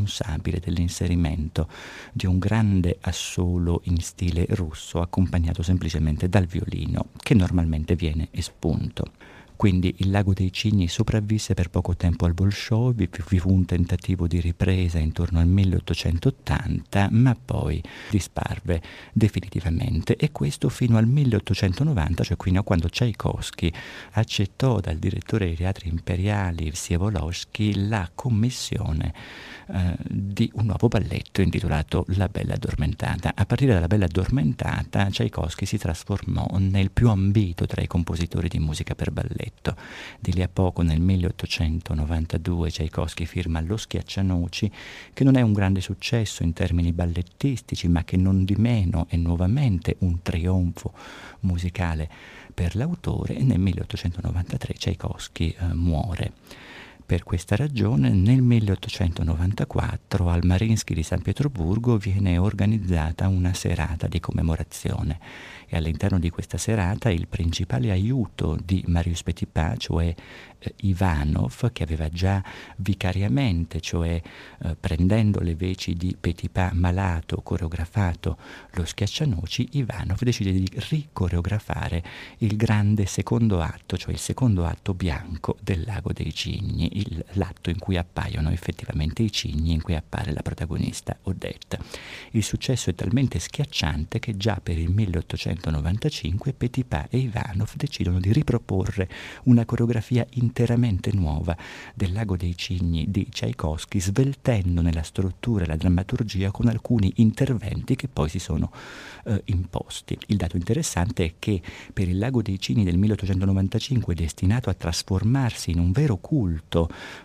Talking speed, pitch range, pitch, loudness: 135 wpm, 85-110 Hz, 95 Hz, -25 LUFS